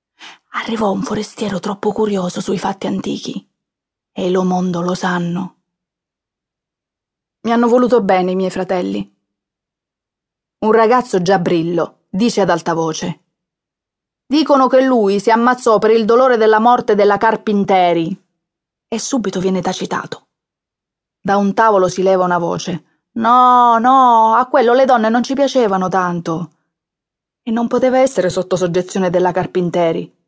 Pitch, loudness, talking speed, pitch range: 195 Hz, -14 LUFS, 135 wpm, 180-230 Hz